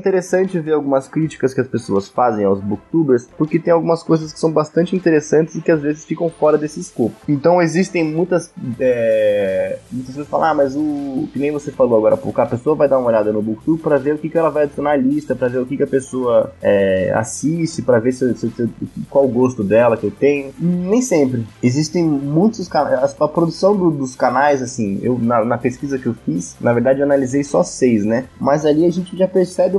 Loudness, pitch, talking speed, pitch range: -17 LUFS, 150 Hz, 225 wpm, 130-170 Hz